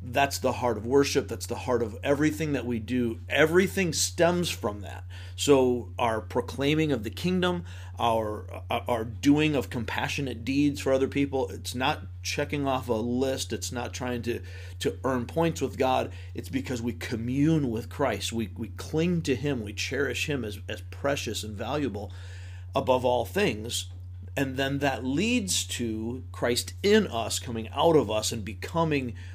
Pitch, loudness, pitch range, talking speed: 115 Hz, -28 LUFS, 95-135 Hz, 170 wpm